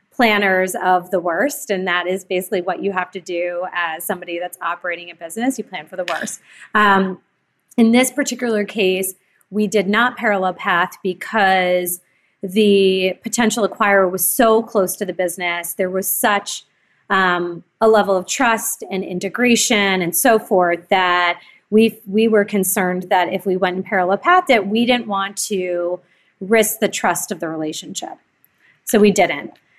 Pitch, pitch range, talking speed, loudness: 190 Hz, 180-215 Hz, 165 wpm, -17 LUFS